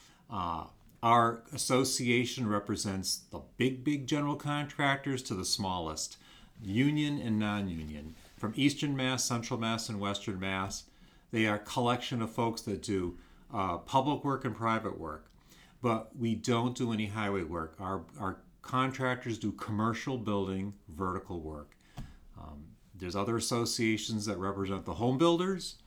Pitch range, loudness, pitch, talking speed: 95-125 Hz, -33 LUFS, 110 Hz, 140 wpm